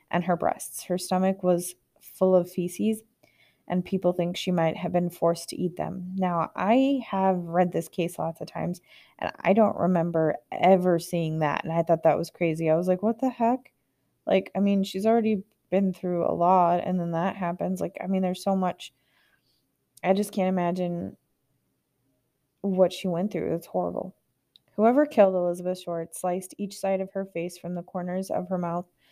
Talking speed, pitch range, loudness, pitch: 190 wpm, 170-190 Hz, -26 LUFS, 180 Hz